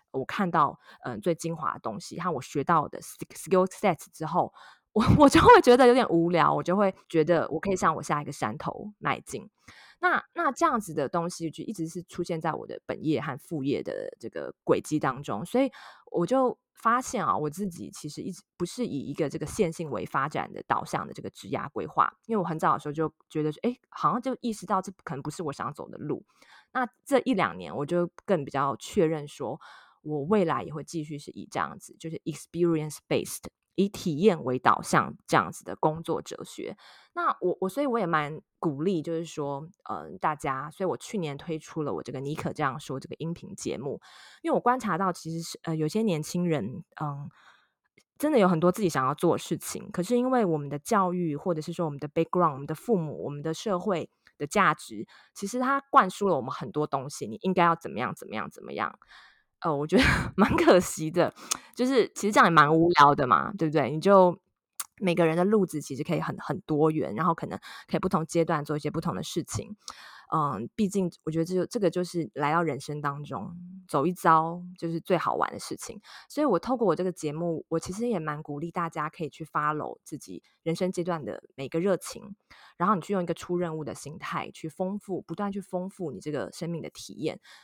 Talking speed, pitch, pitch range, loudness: 335 characters per minute, 170 Hz, 155-195 Hz, -27 LUFS